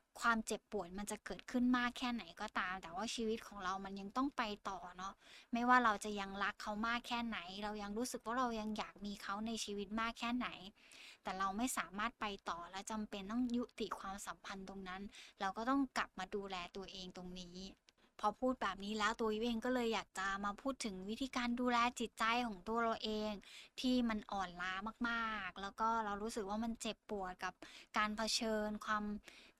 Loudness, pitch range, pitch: -41 LUFS, 195-235 Hz, 215 Hz